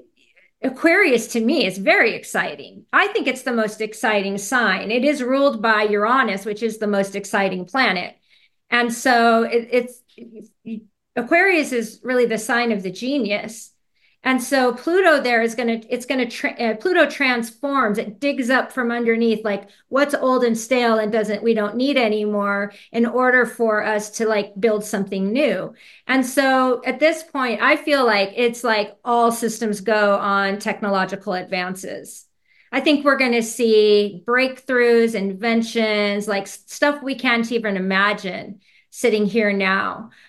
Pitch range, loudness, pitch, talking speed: 210-255 Hz, -19 LUFS, 230 Hz, 160 wpm